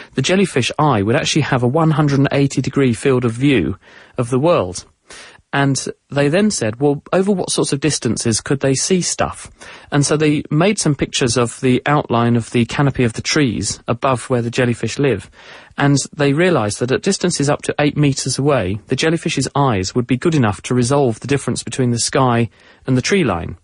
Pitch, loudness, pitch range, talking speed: 135 Hz, -16 LUFS, 120-150 Hz, 200 wpm